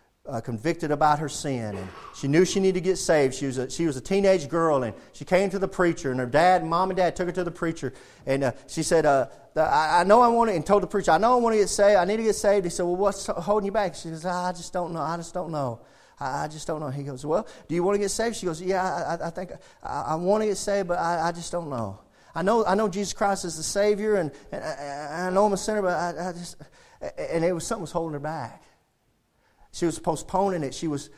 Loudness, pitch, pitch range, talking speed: -25 LUFS, 175 Hz, 150-195 Hz, 290 wpm